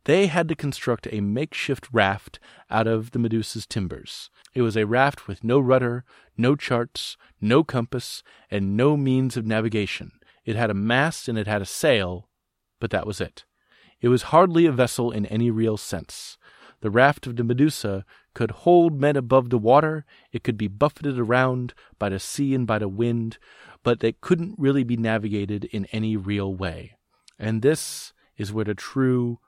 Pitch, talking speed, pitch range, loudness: 120 Hz, 180 wpm, 105-135 Hz, -23 LUFS